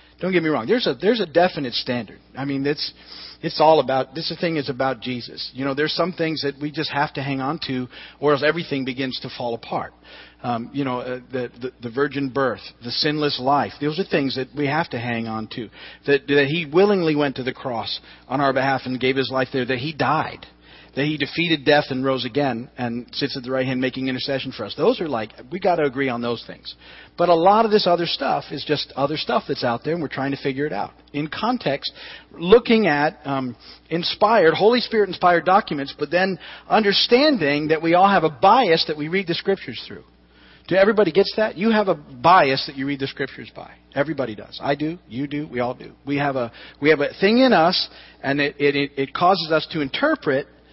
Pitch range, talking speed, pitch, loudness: 130-165 Hz, 230 wpm, 145 Hz, -21 LUFS